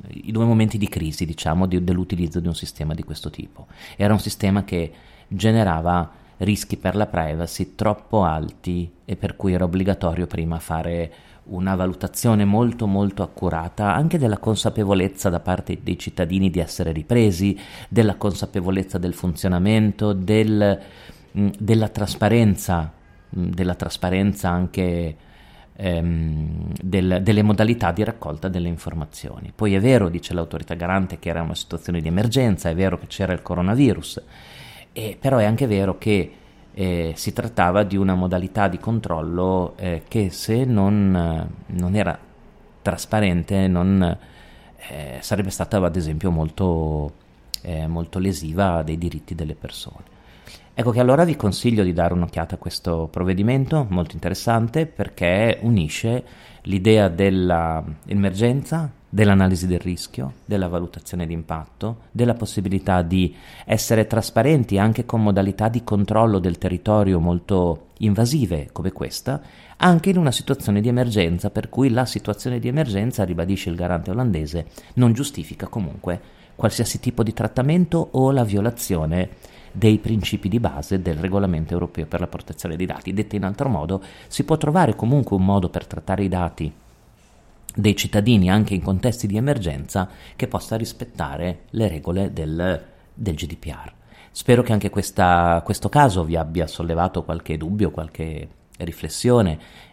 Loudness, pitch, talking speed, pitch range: -21 LUFS, 95 Hz, 145 wpm, 85-105 Hz